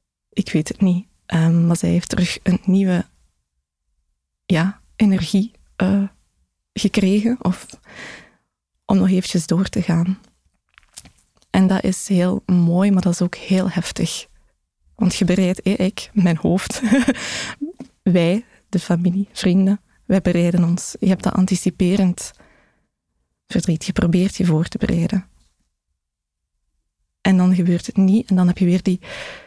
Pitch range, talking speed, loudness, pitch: 175-195 Hz, 140 wpm, -19 LUFS, 185 Hz